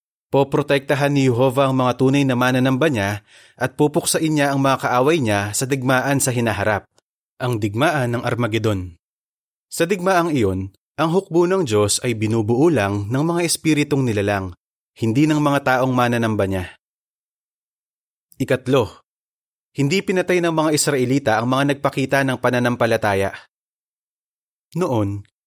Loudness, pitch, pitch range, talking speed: -19 LUFS, 130 Hz, 110-145 Hz, 125 wpm